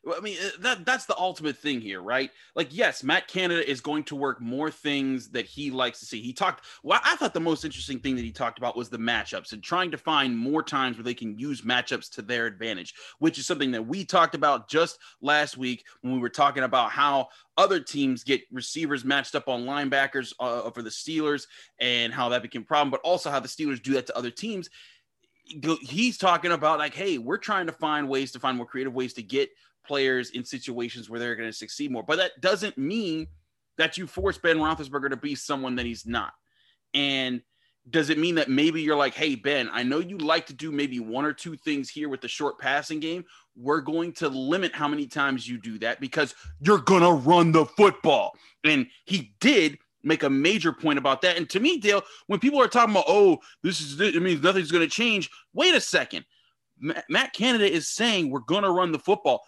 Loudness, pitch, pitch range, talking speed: -25 LUFS, 150 Hz, 130-175 Hz, 225 wpm